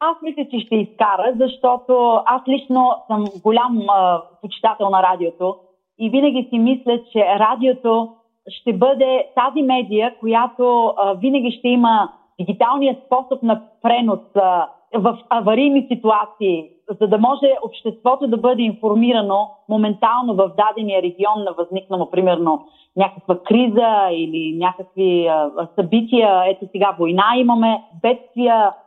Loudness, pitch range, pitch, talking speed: -17 LUFS, 195-245 Hz, 220 Hz, 125 wpm